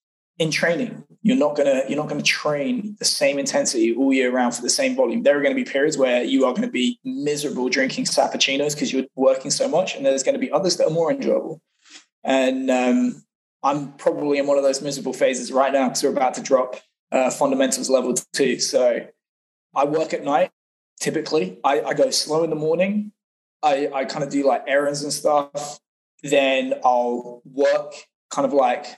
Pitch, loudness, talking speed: 145 Hz, -21 LUFS, 195 wpm